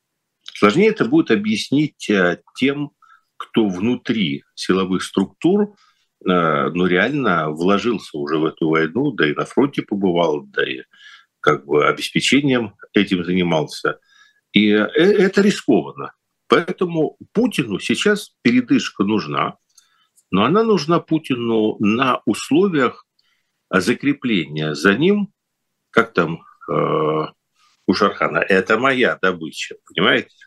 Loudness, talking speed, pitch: -18 LUFS, 105 wpm, 160 Hz